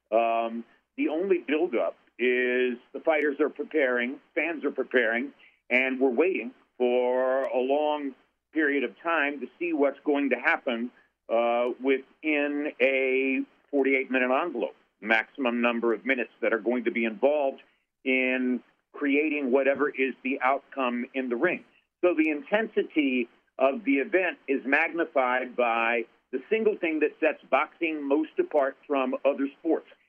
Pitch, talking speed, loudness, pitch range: 135 Hz, 145 wpm, -27 LUFS, 125-150 Hz